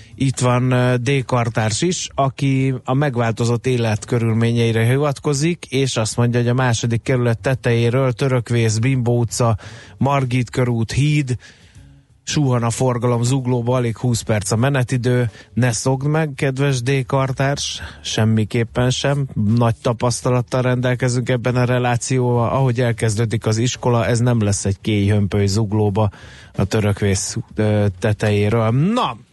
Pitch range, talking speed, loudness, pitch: 115-130 Hz, 125 wpm, -18 LUFS, 120 Hz